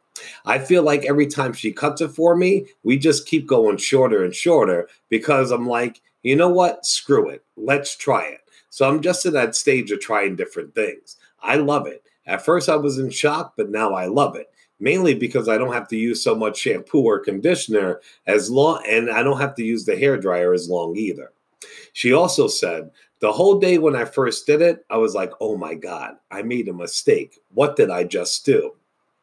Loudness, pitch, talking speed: -19 LUFS, 160 Hz, 210 wpm